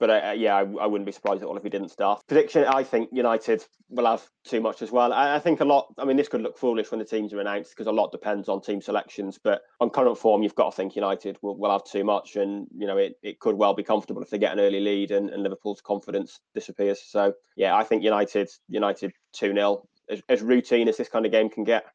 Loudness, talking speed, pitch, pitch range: -25 LUFS, 260 wpm, 105 Hz, 100-120 Hz